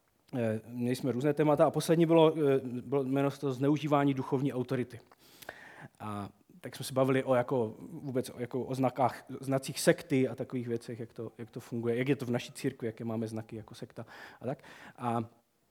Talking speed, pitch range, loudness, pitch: 185 wpm, 120-140 Hz, -32 LUFS, 130 Hz